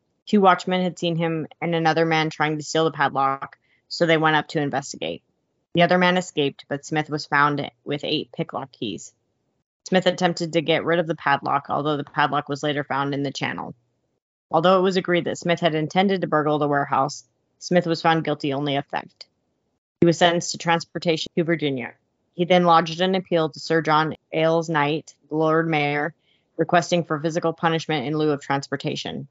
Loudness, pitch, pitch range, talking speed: -22 LUFS, 160 Hz, 145-170 Hz, 195 wpm